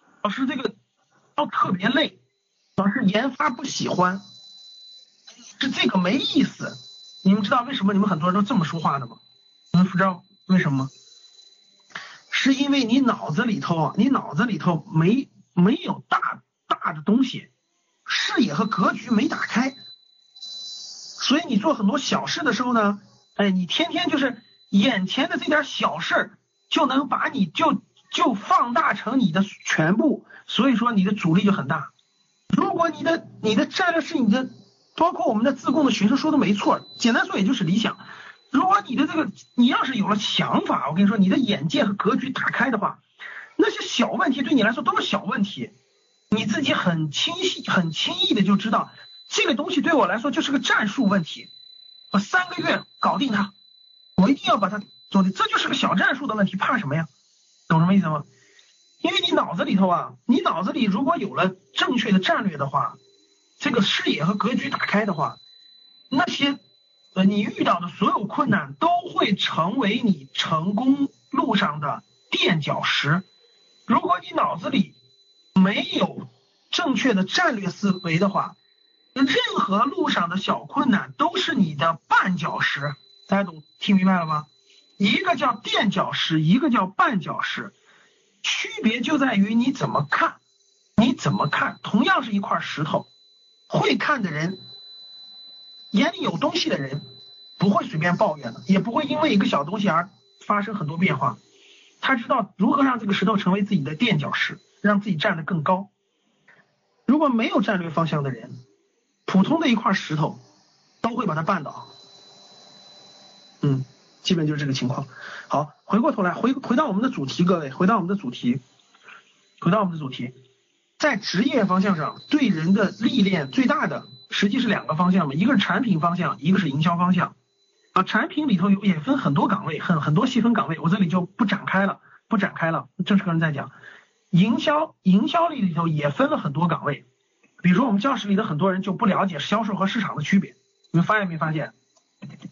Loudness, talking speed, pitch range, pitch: -22 LUFS, 265 characters per minute, 185-275 Hz, 210 Hz